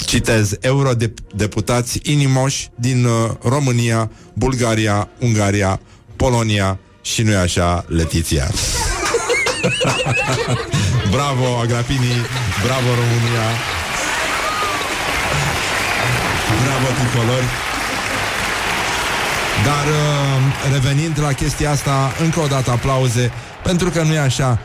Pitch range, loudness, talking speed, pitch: 110-135 Hz, -17 LUFS, 85 wpm, 120 Hz